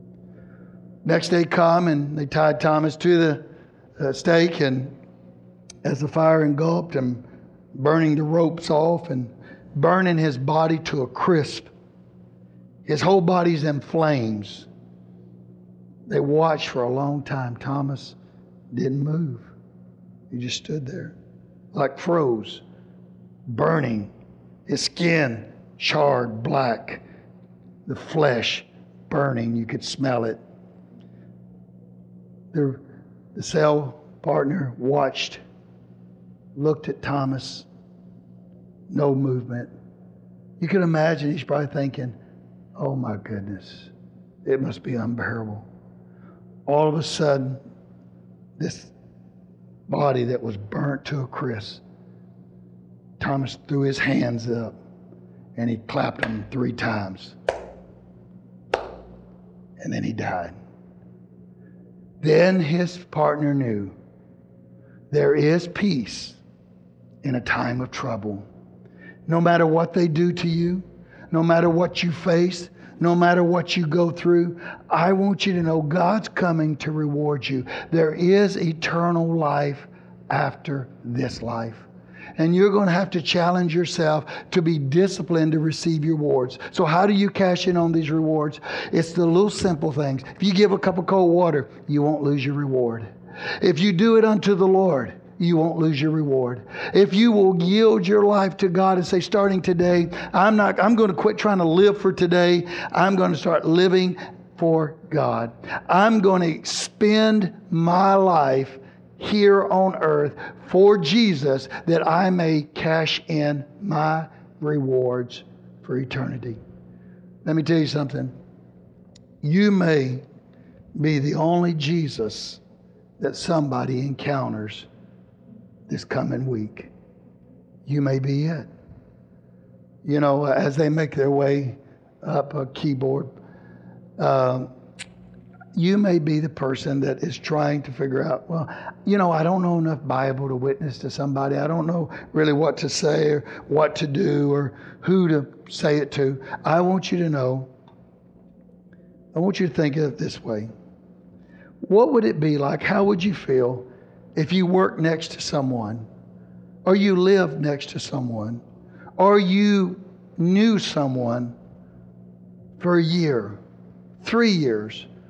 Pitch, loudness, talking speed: 140 Hz, -22 LUFS, 135 wpm